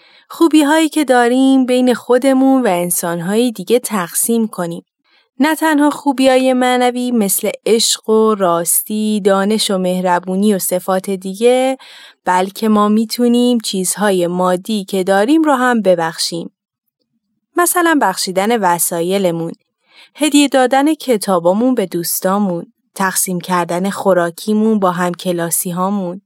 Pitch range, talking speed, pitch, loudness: 180-250 Hz, 115 wpm, 210 Hz, -14 LUFS